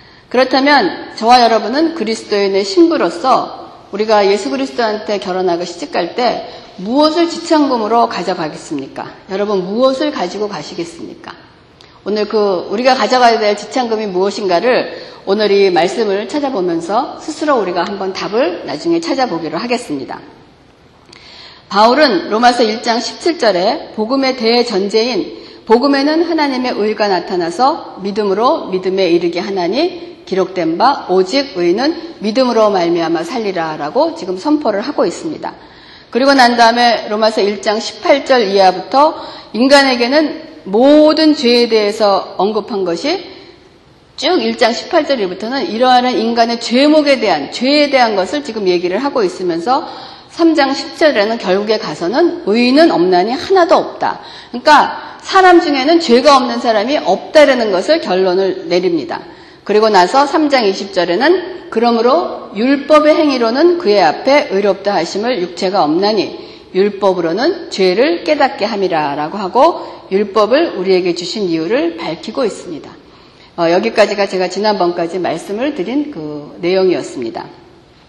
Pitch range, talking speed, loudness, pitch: 195-305 Hz, 320 characters per minute, -13 LUFS, 235 Hz